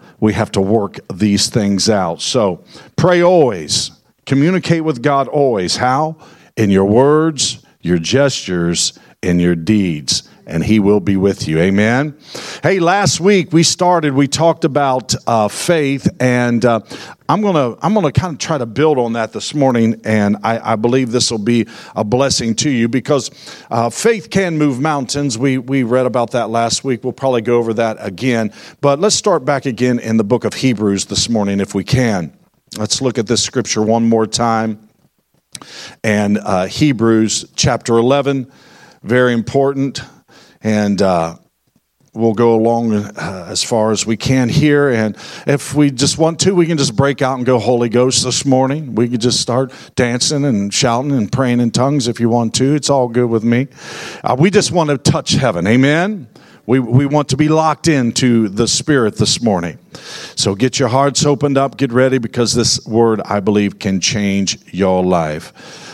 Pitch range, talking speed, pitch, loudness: 110-140 Hz, 180 wpm, 125 Hz, -14 LUFS